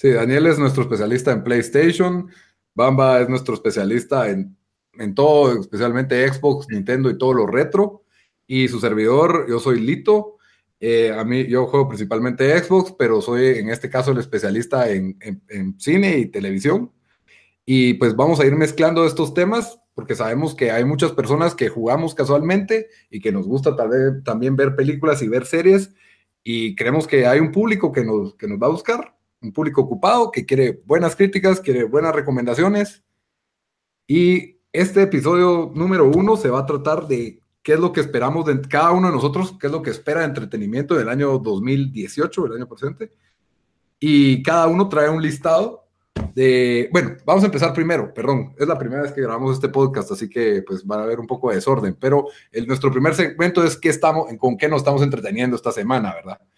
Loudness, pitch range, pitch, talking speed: -18 LUFS, 125-175 Hz, 145 Hz, 190 wpm